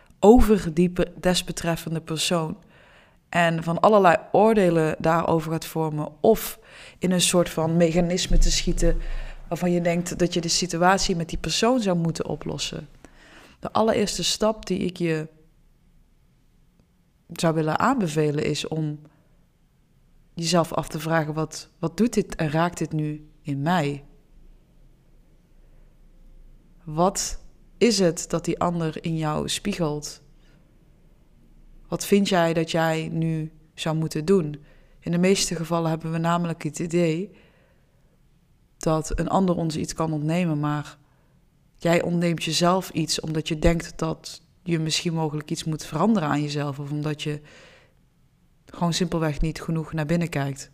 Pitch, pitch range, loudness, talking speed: 165 Hz, 155-175 Hz, -24 LUFS, 140 wpm